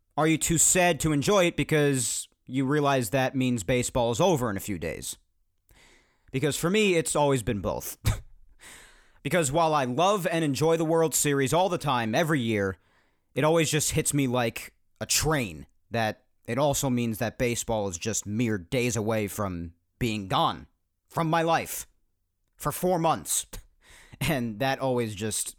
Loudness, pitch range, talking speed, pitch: -26 LUFS, 105-155 Hz, 170 wpm, 130 Hz